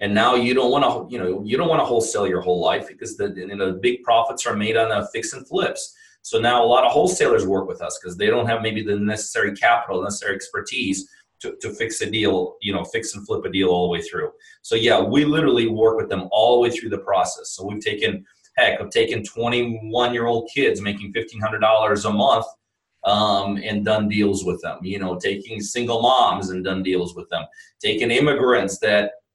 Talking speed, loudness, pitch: 225 wpm, -20 LUFS, 115 Hz